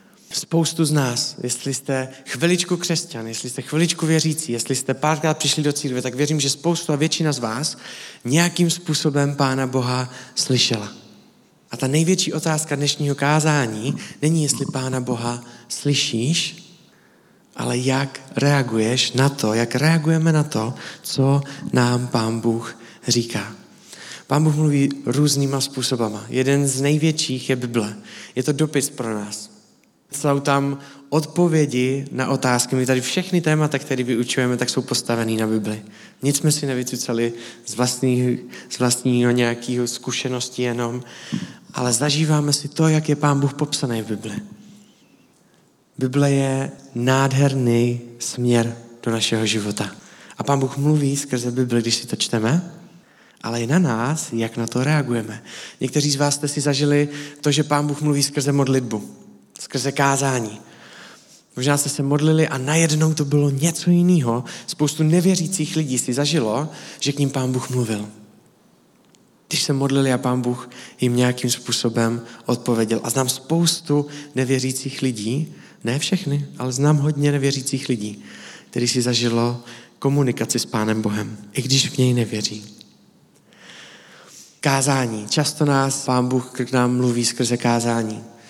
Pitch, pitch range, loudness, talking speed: 135 Hz, 120-150 Hz, -20 LUFS, 145 wpm